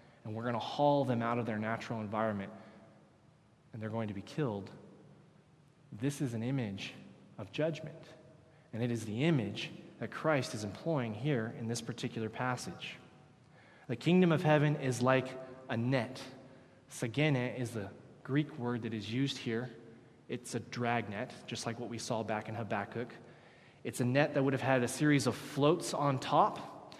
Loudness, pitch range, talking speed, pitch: -35 LUFS, 115-145 Hz, 175 wpm, 125 Hz